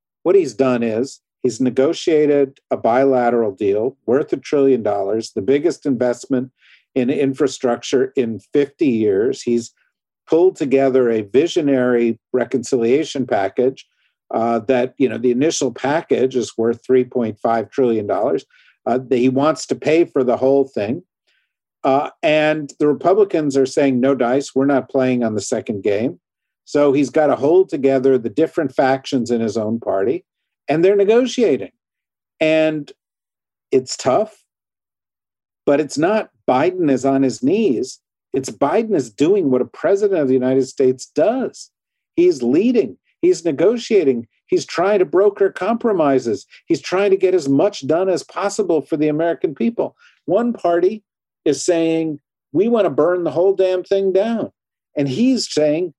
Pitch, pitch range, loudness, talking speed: 140 Hz, 130-205 Hz, -18 LUFS, 155 wpm